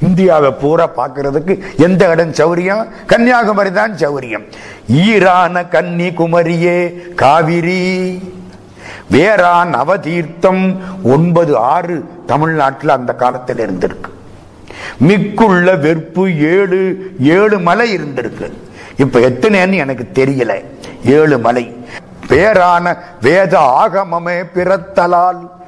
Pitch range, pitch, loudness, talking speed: 155-190 Hz, 175 Hz, -11 LUFS, 70 wpm